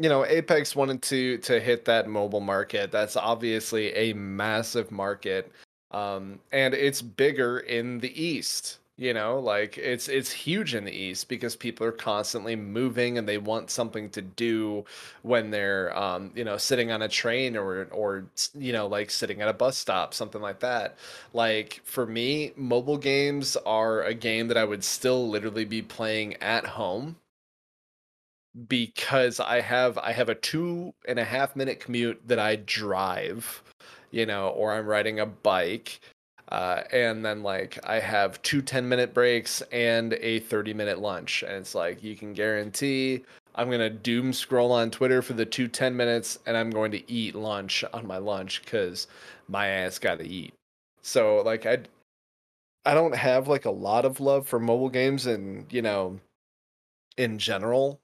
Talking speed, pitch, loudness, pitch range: 175 wpm, 115 Hz, -27 LUFS, 105-130 Hz